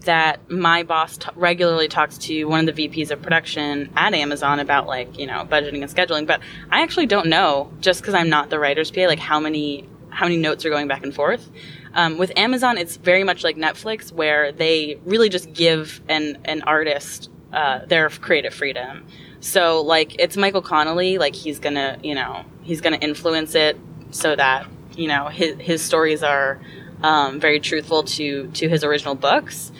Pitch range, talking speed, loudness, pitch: 150-170 Hz, 190 wpm, -19 LUFS, 155 Hz